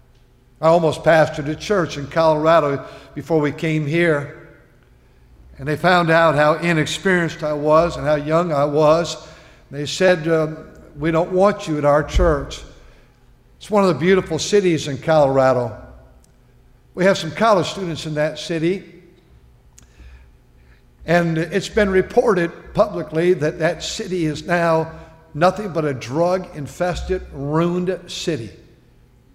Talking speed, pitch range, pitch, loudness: 140 wpm, 145-175 Hz, 160 Hz, -18 LUFS